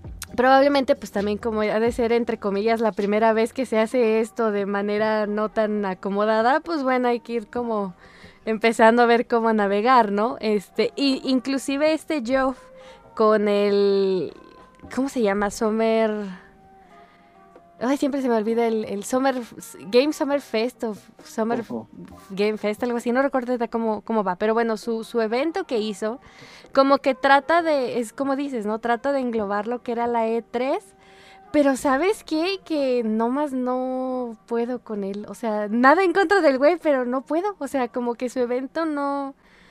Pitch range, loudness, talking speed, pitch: 215-270 Hz, -22 LUFS, 175 wpm, 235 Hz